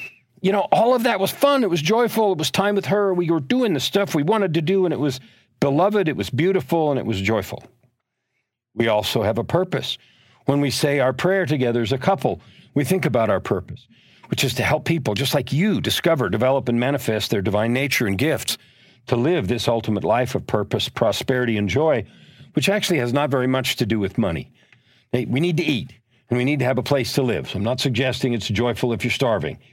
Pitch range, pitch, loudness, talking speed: 120-170 Hz, 135 Hz, -21 LUFS, 230 wpm